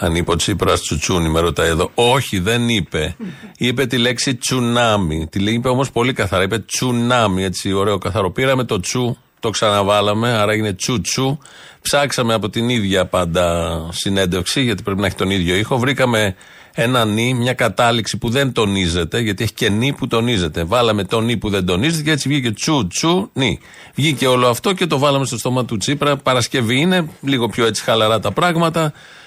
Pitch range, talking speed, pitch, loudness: 100-130 Hz, 190 wpm, 115 Hz, -17 LUFS